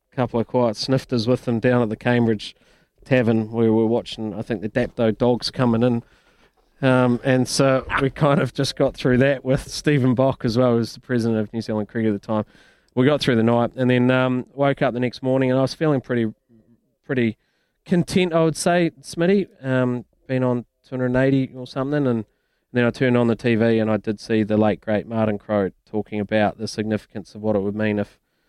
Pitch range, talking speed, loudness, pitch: 110-130 Hz, 215 wpm, -21 LUFS, 125 Hz